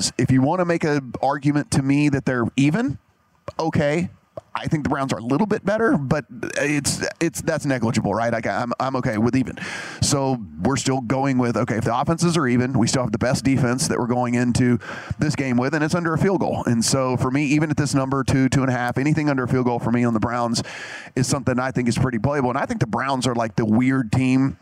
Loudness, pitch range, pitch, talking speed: -21 LUFS, 120-145 Hz, 130 Hz, 255 wpm